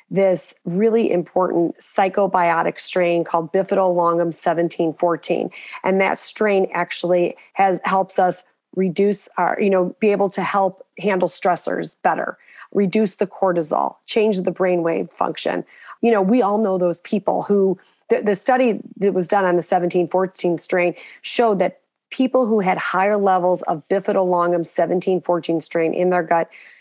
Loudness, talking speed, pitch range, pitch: -19 LUFS, 145 wpm, 175-200 Hz, 185 Hz